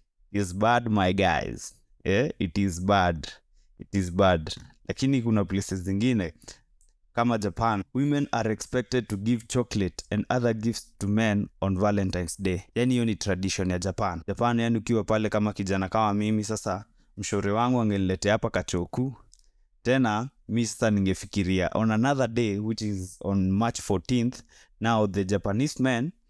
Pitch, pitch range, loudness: 105 Hz, 95-115 Hz, -27 LUFS